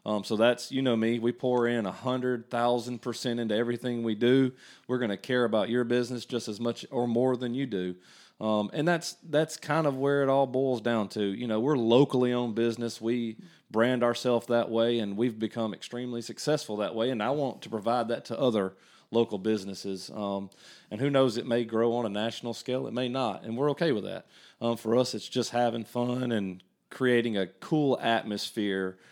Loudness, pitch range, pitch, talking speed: -29 LUFS, 110-125 Hz, 120 Hz, 210 wpm